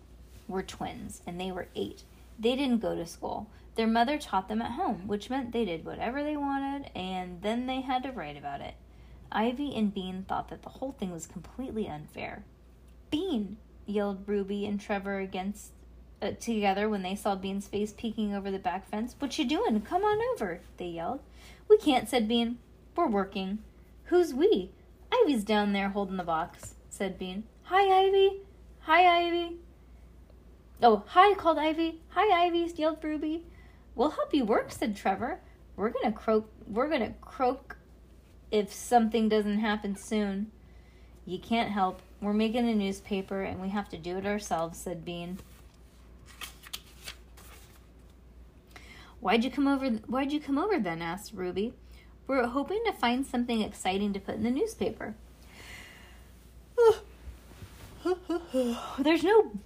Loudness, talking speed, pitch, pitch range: -30 LUFS, 155 wpm, 225 Hz, 195-280 Hz